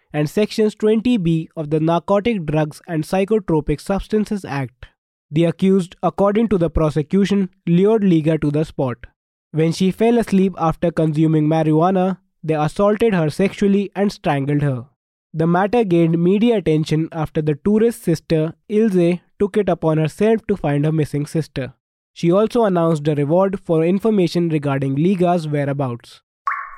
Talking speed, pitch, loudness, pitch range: 145 wpm, 170 Hz, -18 LUFS, 155-200 Hz